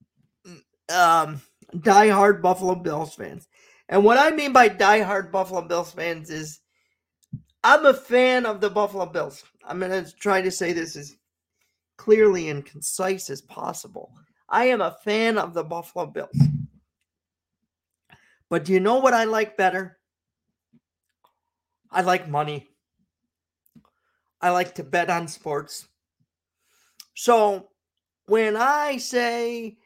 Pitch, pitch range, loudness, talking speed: 190 Hz, 165-220 Hz, -21 LUFS, 135 wpm